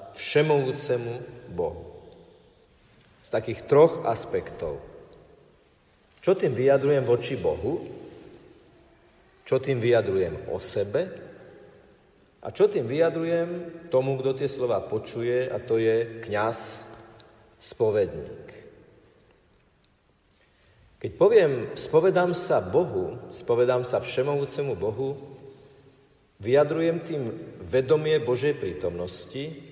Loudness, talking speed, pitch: -25 LUFS, 90 wpm, 145 Hz